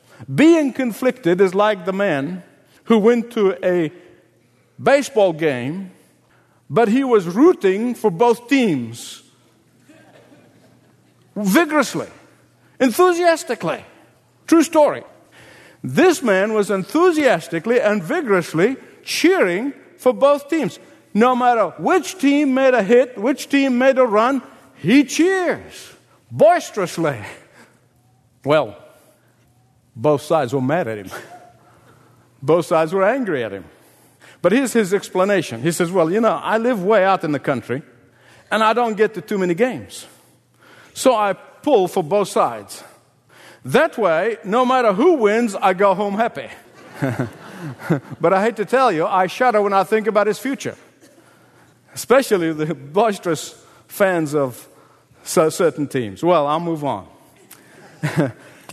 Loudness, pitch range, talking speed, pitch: -18 LUFS, 160-250 Hz, 130 wpm, 200 Hz